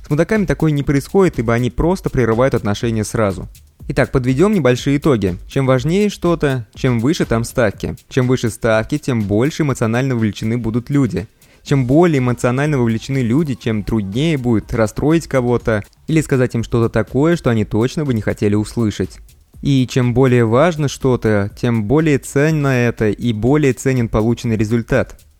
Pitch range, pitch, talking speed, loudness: 110-140 Hz, 125 Hz, 160 wpm, -16 LUFS